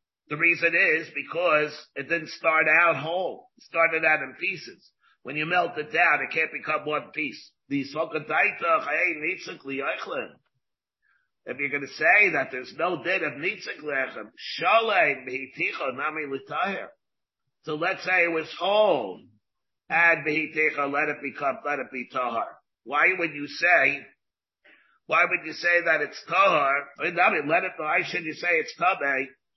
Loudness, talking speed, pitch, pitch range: -24 LUFS, 140 wpm, 155 Hz, 145-170 Hz